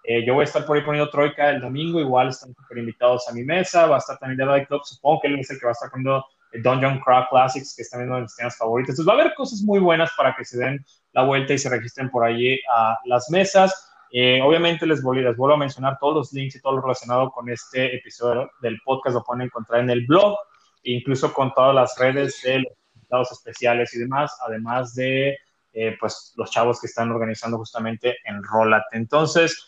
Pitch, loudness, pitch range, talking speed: 130 Hz, -21 LUFS, 120-145 Hz, 235 wpm